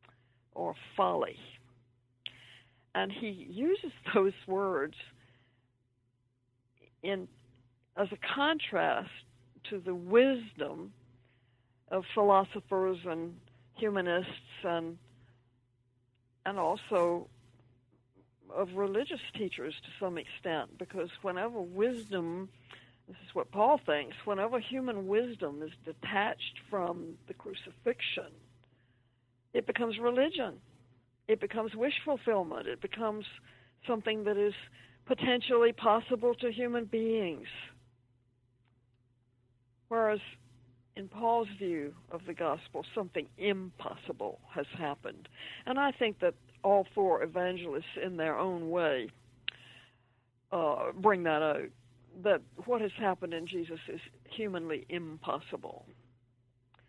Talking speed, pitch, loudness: 100 wpm, 165 Hz, -33 LUFS